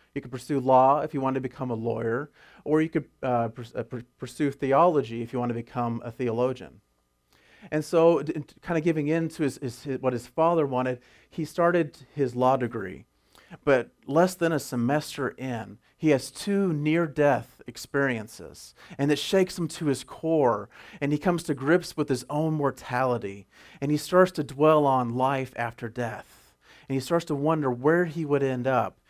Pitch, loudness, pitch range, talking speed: 140 Hz, -26 LUFS, 125-155 Hz, 190 wpm